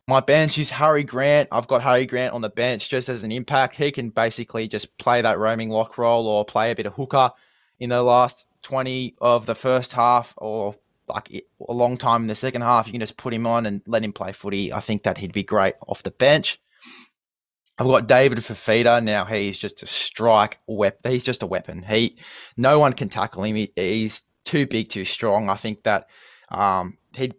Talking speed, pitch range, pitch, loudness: 215 wpm, 110-125 Hz, 115 Hz, -21 LUFS